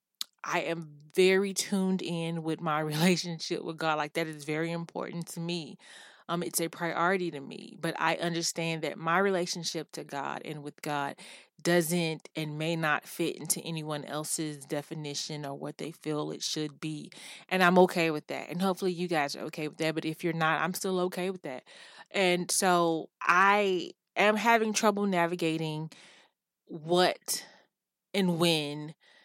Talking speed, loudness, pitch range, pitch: 170 wpm, -30 LUFS, 155-180 Hz, 165 Hz